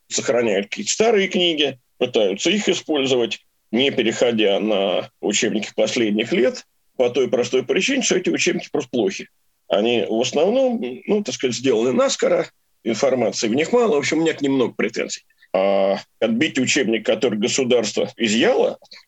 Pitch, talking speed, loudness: 175 Hz, 145 wpm, -19 LUFS